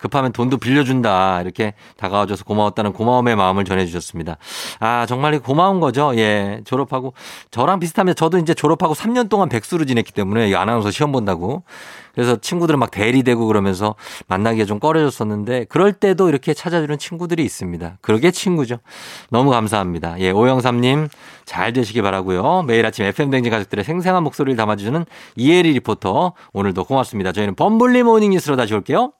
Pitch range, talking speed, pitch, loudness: 105-155 Hz, 435 characters per minute, 125 Hz, -17 LUFS